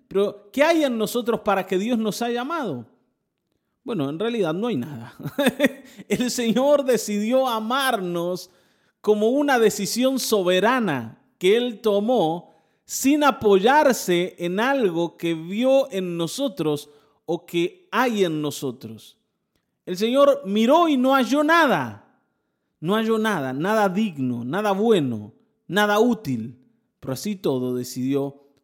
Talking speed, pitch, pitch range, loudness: 130 wpm, 210 Hz, 170-245 Hz, -22 LUFS